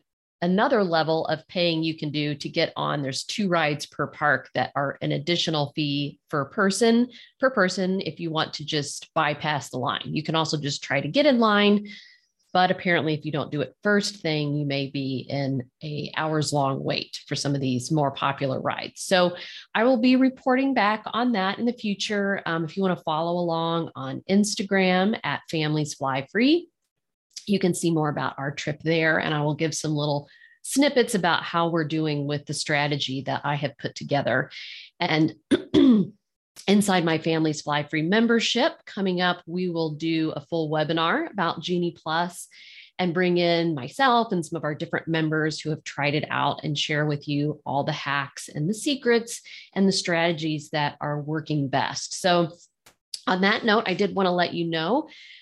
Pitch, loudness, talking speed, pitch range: 165 Hz, -24 LUFS, 190 wpm, 150-195 Hz